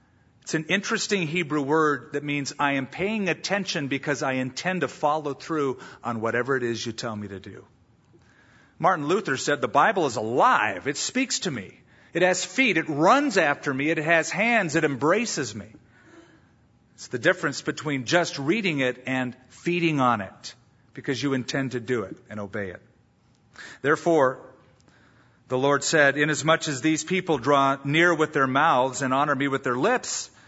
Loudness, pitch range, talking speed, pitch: -24 LUFS, 130-165 Hz, 175 wpm, 145 Hz